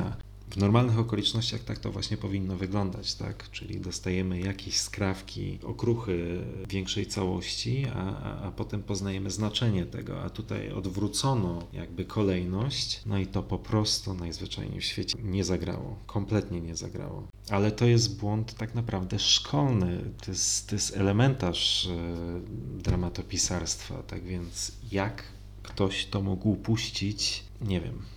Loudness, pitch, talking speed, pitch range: -30 LUFS, 100 Hz, 135 wpm, 95-110 Hz